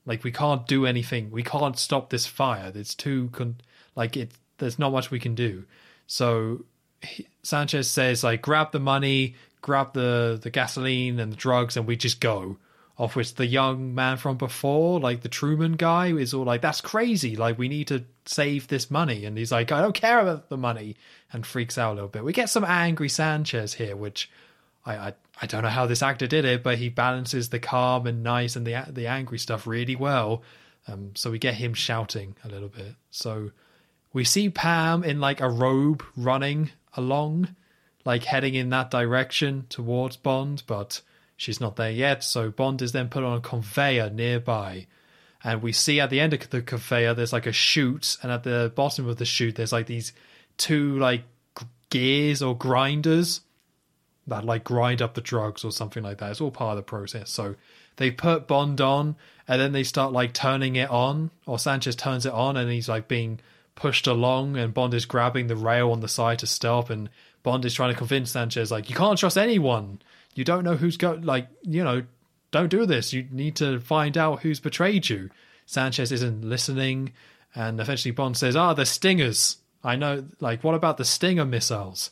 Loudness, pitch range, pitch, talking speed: -25 LUFS, 115-140 Hz, 125 Hz, 200 wpm